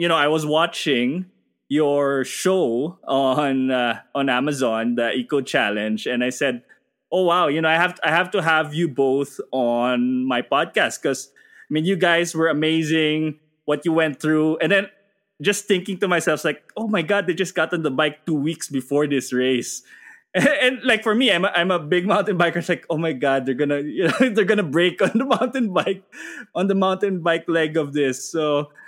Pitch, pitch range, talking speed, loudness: 160 Hz, 145-190 Hz, 210 wpm, -20 LUFS